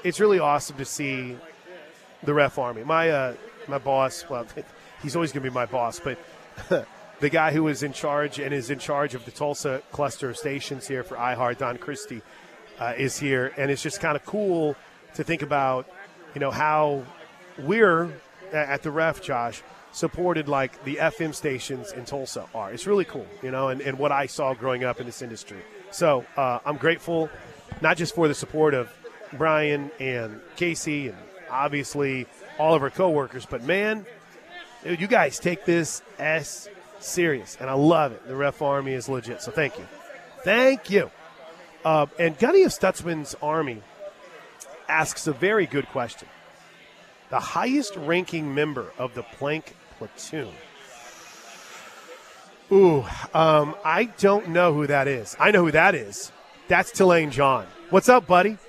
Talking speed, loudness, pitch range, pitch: 170 wpm, -24 LUFS, 135-170 Hz, 150 Hz